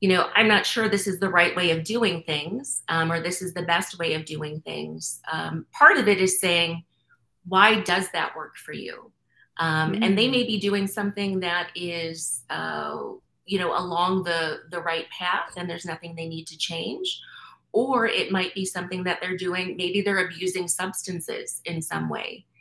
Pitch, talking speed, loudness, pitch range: 180 Hz, 195 wpm, -24 LUFS, 170-200 Hz